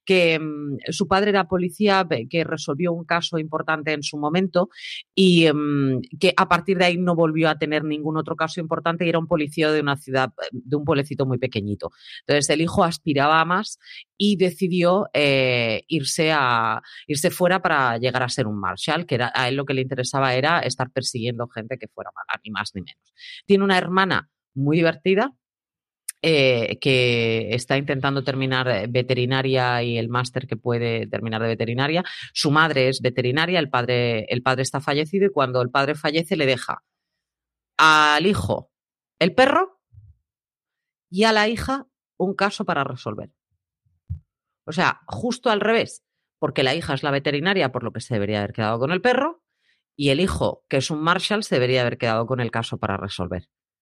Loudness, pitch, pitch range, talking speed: -21 LUFS, 145 Hz, 125-175 Hz, 185 wpm